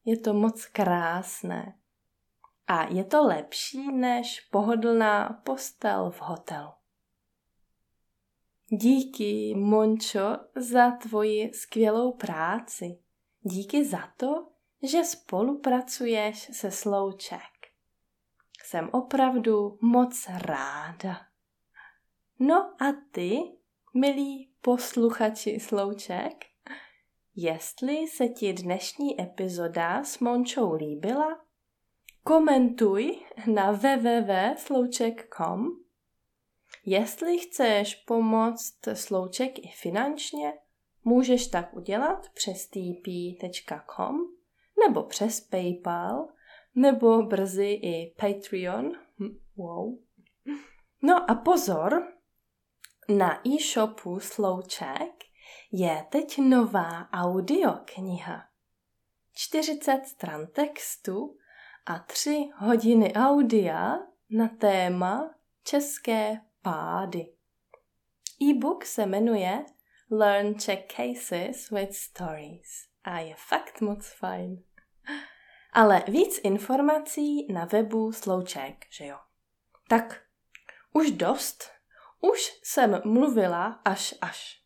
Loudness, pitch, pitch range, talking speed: -27 LUFS, 225 Hz, 195-270 Hz, 85 wpm